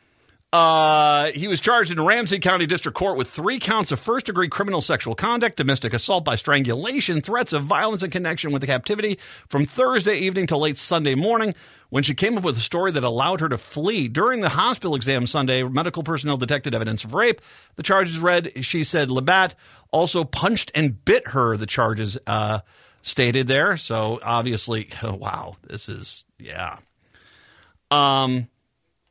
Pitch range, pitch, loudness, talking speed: 125-185 Hz, 150 Hz, -21 LUFS, 175 wpm